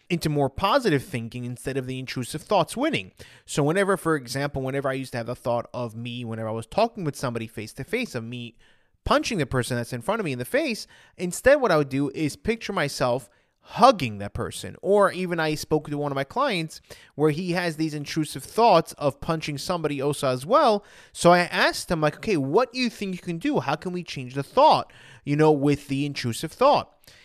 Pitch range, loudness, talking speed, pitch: 125-170 Hz, -24 LUFS, 225 wpm, 145 Hz